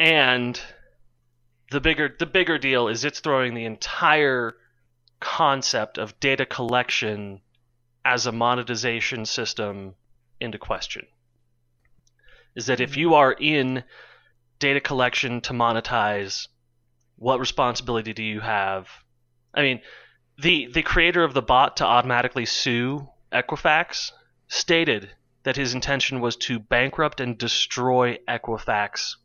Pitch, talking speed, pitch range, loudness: 120 Hz, 120 wpm, 115-135 Hz, -22 LUFS